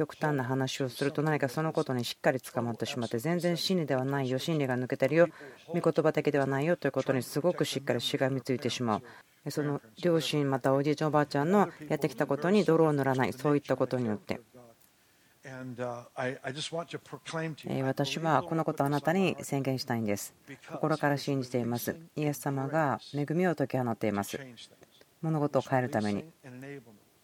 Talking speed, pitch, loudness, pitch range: 375 characters per minute, 140 Hz, -30 LUFS, 130-155 Hz